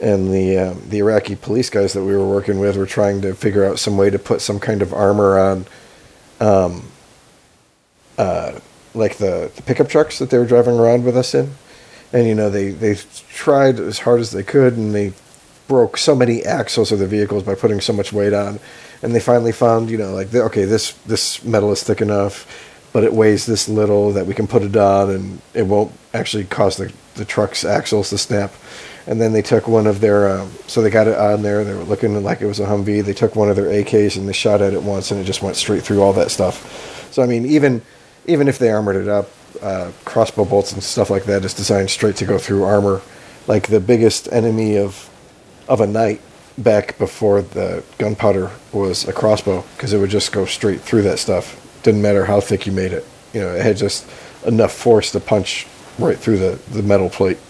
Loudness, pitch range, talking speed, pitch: -17 LUFS, 100-110 Hz, 225 wpm, 105 Hz